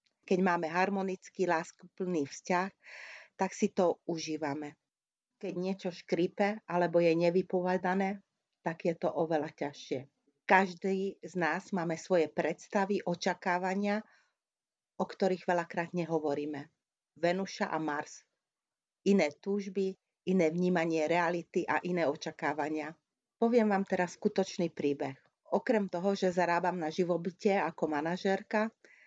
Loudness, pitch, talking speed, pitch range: -33 LUFS, 180 Hz, 115 wpm, 165-195 Hz